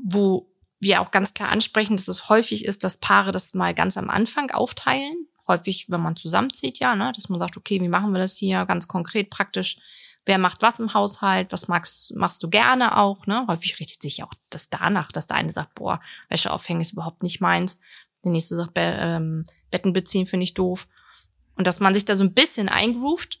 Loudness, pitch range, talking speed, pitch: -19 LUFS, 180-215 Hz, 215 wpm, 195 Hz